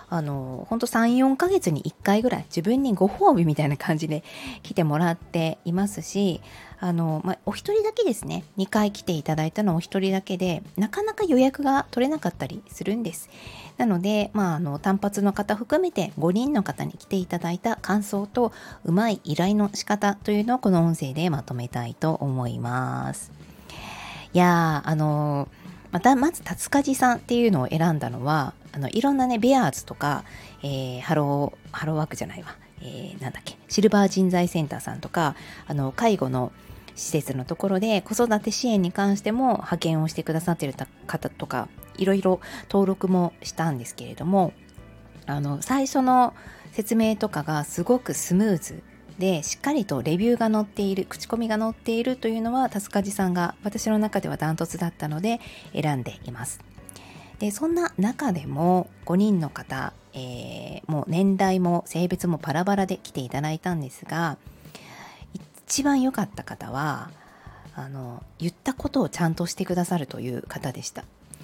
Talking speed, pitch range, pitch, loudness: 340 characters per minute, 155-215 Hz, 185 Hz, -25 LUFS